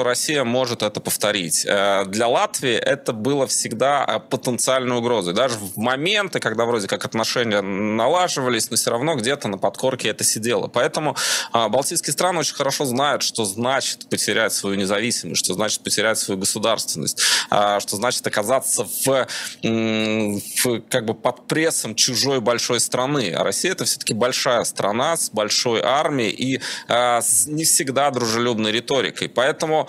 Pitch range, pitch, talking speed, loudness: 110-135 Hz, 120 Hz, 150 wpm, -20 LUFS